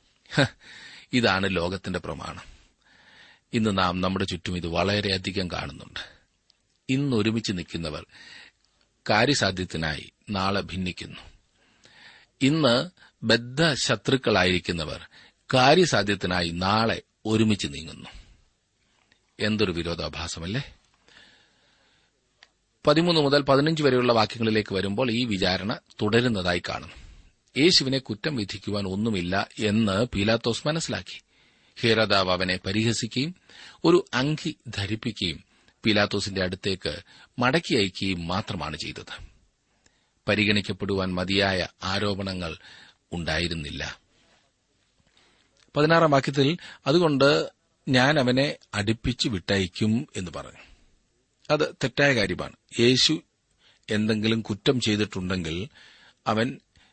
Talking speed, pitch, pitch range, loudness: 75 wpm, 105 Hz, 95-125 Hz, -25 LUFS